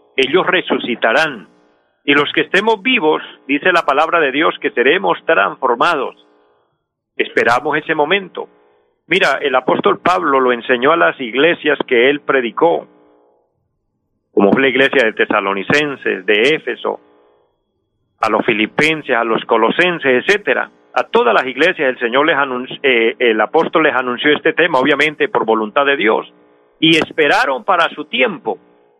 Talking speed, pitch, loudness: 145 wpm, 125 Hz, -14 LUFS